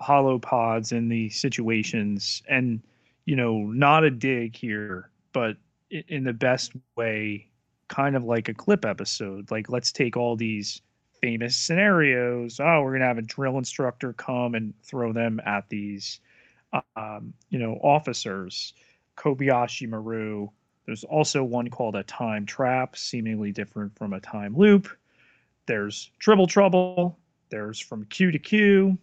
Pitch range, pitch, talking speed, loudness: 110-140 Hz, 120 Hz, 145 wpm, -25 LUFS